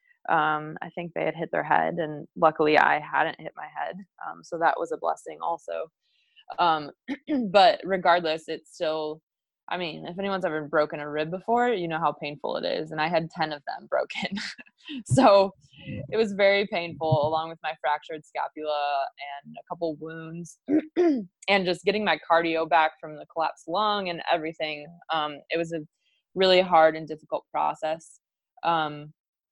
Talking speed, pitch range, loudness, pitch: 175 wpm, 155-195 Hz, -26 LUFS, 165 Hz